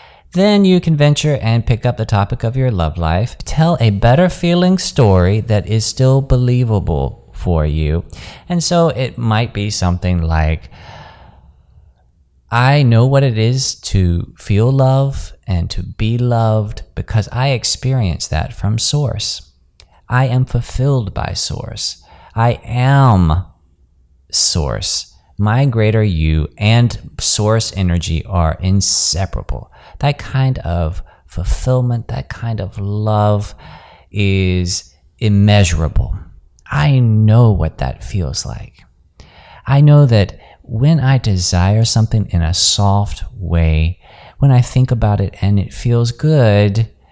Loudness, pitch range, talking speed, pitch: -15 LUFS, 85-125 Hz, 130 wpm, 105 Hz